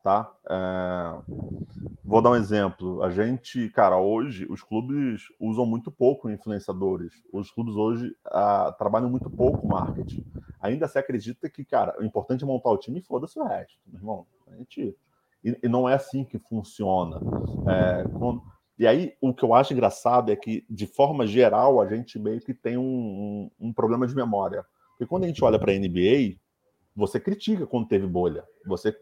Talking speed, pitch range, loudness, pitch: 180 wpm, 100-125 Hz, -25 LUFS, 110 Hz